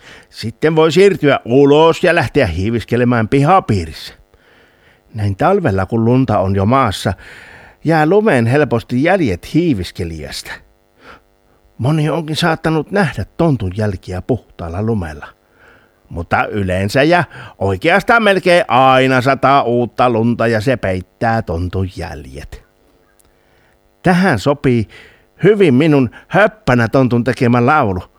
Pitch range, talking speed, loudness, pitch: 95-145 Hz, 105 wpm, -14 LUFS, 120 Hz